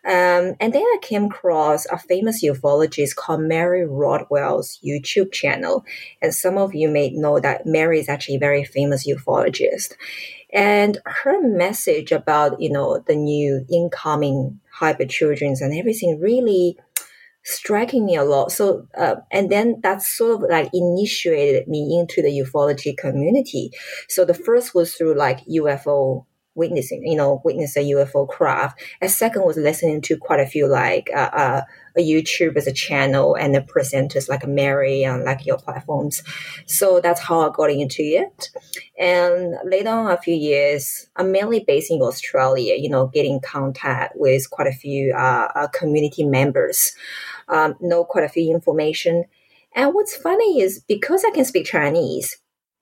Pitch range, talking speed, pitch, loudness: 145-200 Hz, 165 wpm, 165 Hz, -19 LUFS